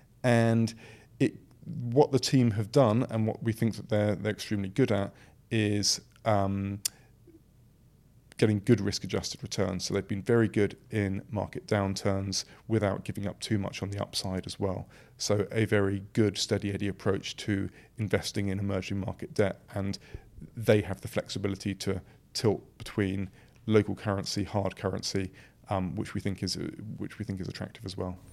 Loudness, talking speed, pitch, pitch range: -30 LUFS, 165 wpm, 105 Hz, 100-115 Hz